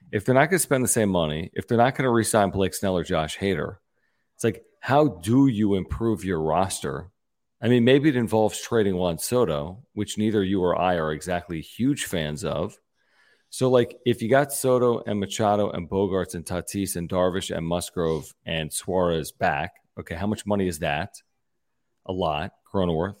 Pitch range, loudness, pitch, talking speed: 90-115 Hz, -24 LUFS, 100 Hz, 195 wpm